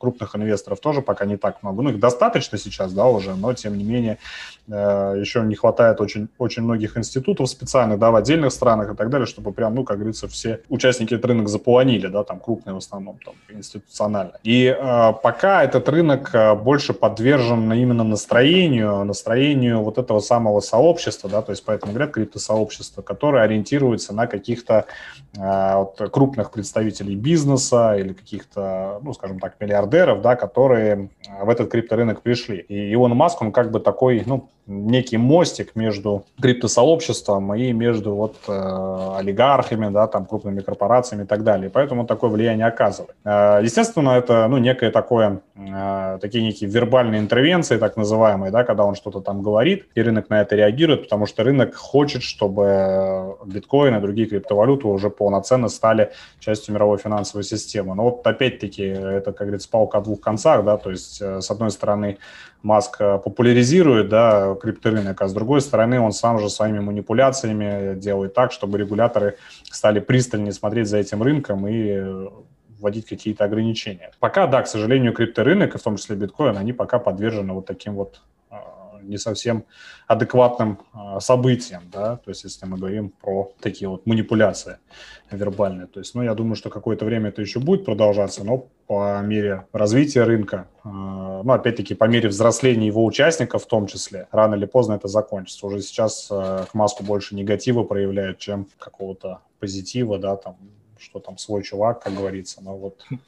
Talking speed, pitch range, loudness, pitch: 165 wpm, 100-120 Hz, -19 LUFS, 105 Hz